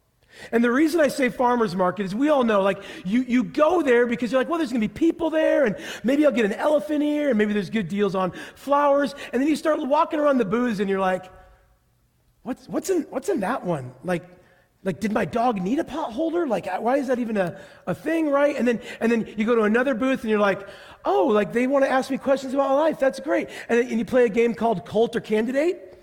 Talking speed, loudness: 255 wpm, -23 LUFS